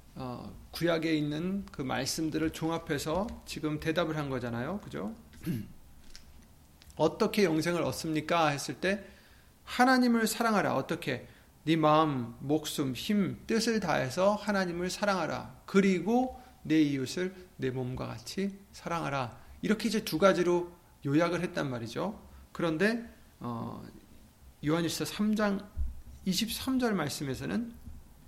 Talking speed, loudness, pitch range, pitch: 250 characters per minute, -31 LUFS, 140-195 Hz, 165 Hz